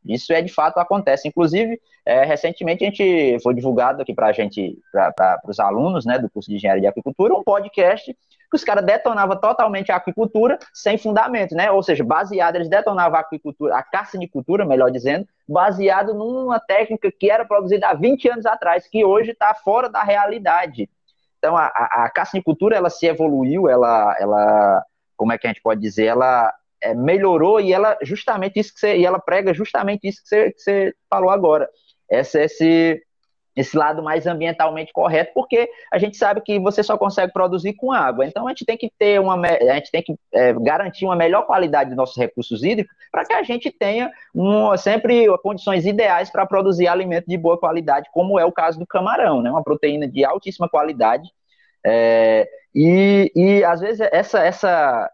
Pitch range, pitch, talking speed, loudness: 160-210 Hz, 185 Hz, 195 wpm, -18 LUFS